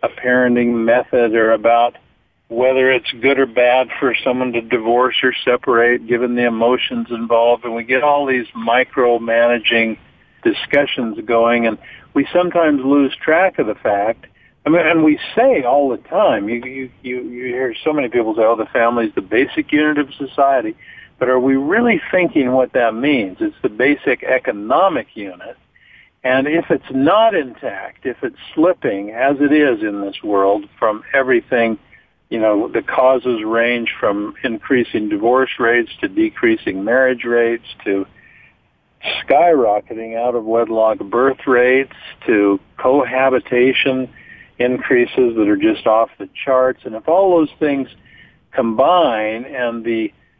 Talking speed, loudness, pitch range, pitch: 150 wpm, -16 LUFS, 115-145 Hz, 125 Hz